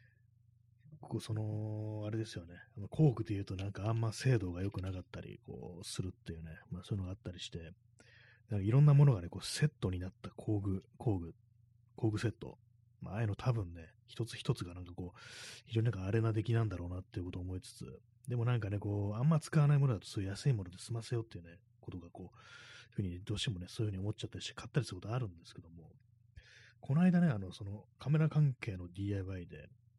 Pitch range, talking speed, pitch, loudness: 95-120 Hz, 420 characters per minute, 110 Hz, -36 LUFS